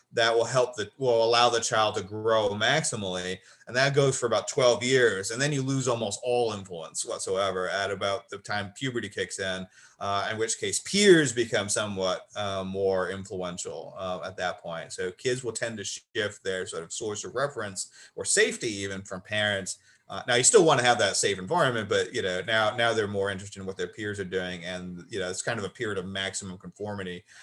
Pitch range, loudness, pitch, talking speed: 95-120 Hz, -27 LUFS, 105 Hz, 215 wpm